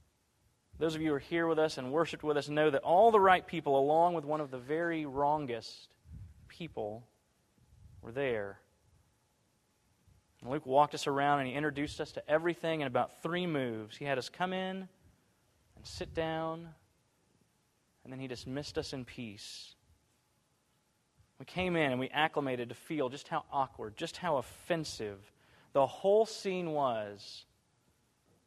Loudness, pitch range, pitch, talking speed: -33 LUFS, 120-160 Hz, 145 Hz, 160 wpm